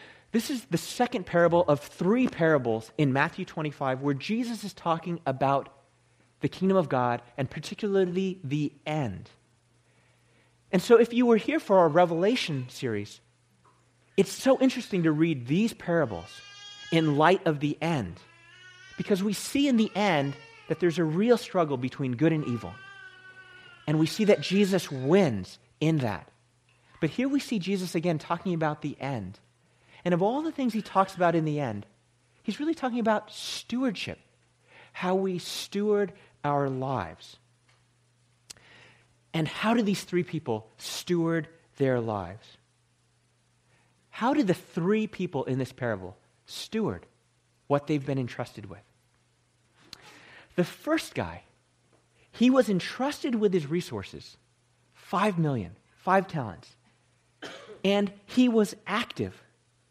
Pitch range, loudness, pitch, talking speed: 125-205 Hz, -27 LUFS, 160 Hz, 140 wpm